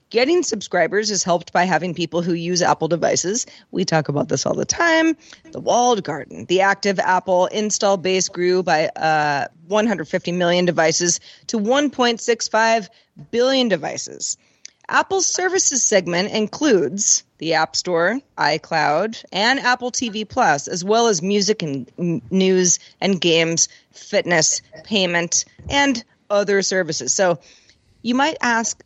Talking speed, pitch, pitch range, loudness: 135 wpm, 195 Hz, 175-230 Hz, -19 LUFS